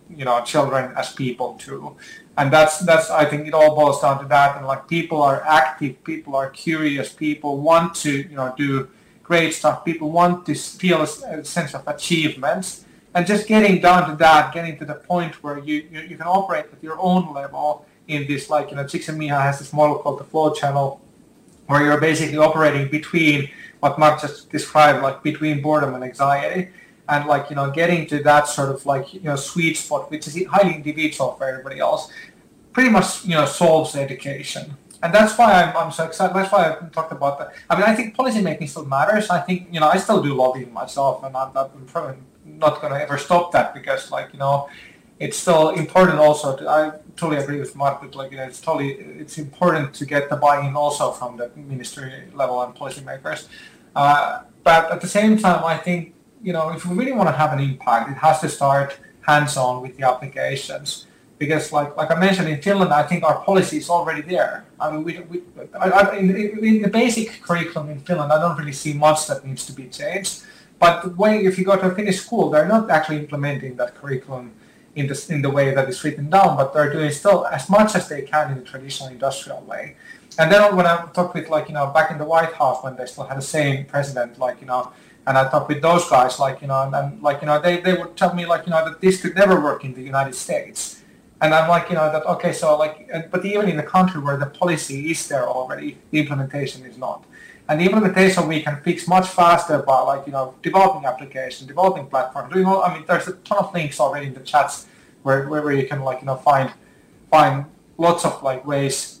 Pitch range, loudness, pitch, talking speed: 140-175 Hz, -19 LUFS, 155 Hz, 225 wpm